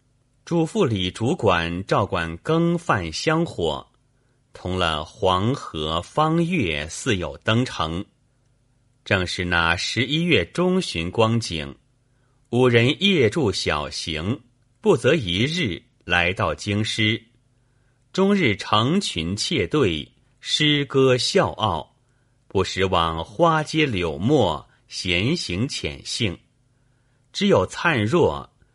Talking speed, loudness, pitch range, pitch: 145 characters per minute, -22 LUFS, 90-135 Hz, 120 Hz